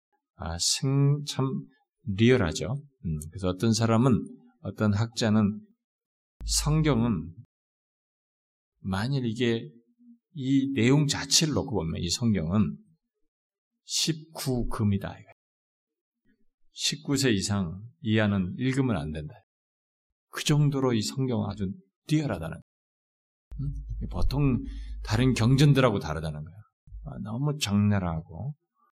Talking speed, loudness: 200 characters per minute, -27 LUFS